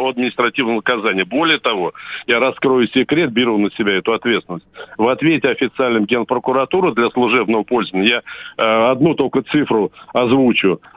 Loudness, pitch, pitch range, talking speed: -16 LUFS, 120 Hz, 110-130 Hz, 135 wpm